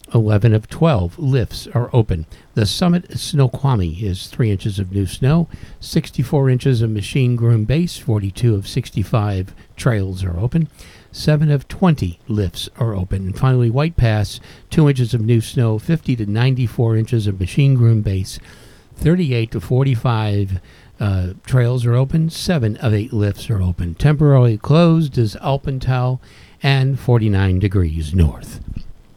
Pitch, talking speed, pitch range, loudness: 115 Hz, 145 wpm, 100-135 Hz, -18 LUFS